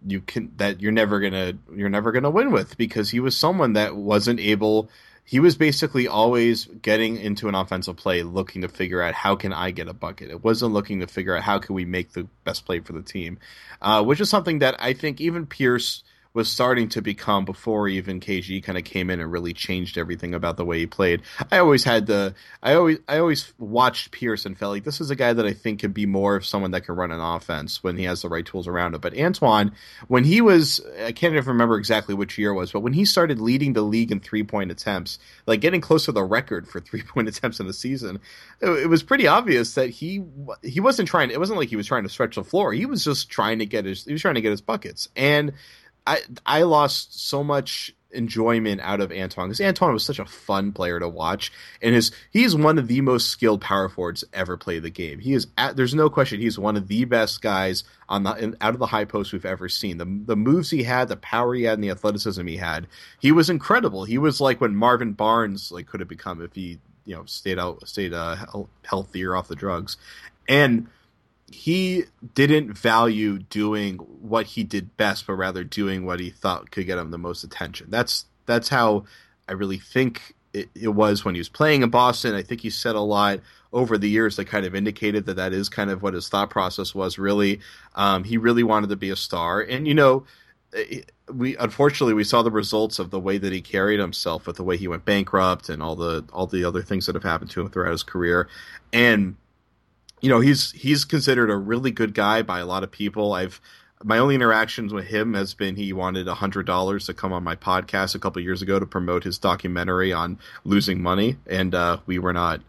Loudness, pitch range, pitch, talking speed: -22 LUFS, 95-120 Hz, 105 Hz, 235 wpm